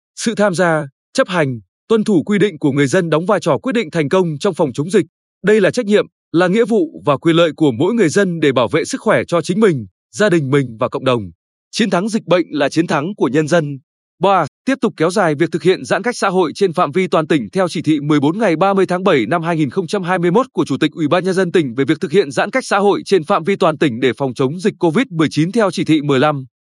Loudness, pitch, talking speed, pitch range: -15 LUFS, 175 Hz, 265 wpm, 150-200 Hz